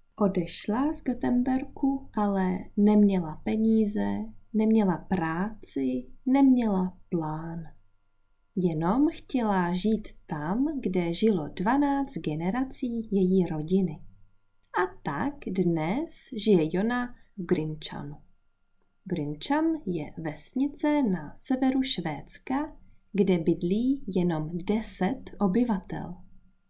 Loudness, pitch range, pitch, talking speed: -28 LUFS, 160-245 Hz, 190 Hz, 85 wpm